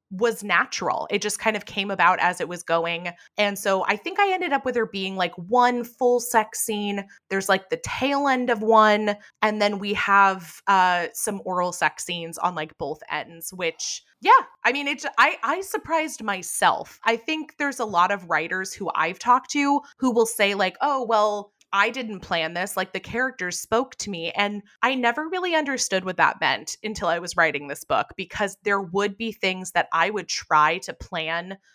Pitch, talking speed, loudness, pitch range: 205 Hz, 205 wpm, -23 LUFS, 185-240 Hz